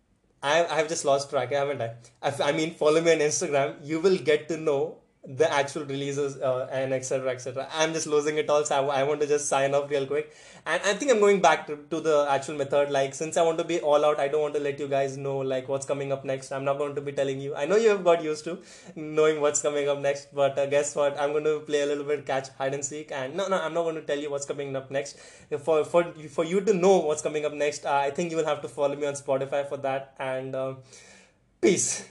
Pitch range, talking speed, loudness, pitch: 140-155 Hz, 265 wpm, -26 LUFS, 145 Hz